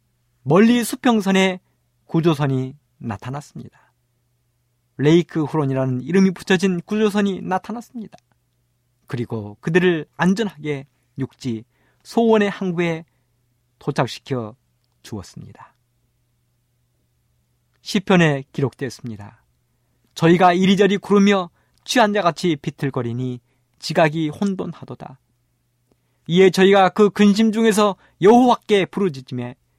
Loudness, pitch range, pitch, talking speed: -18 LUFS, 120-190 Hz, 150 Hz, 250 characters per minute